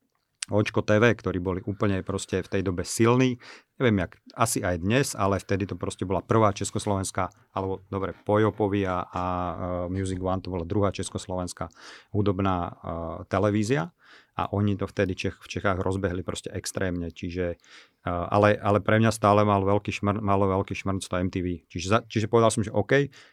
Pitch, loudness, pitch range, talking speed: 100 Hz, -26 LUFS, 95-105 Hz, 175 wpm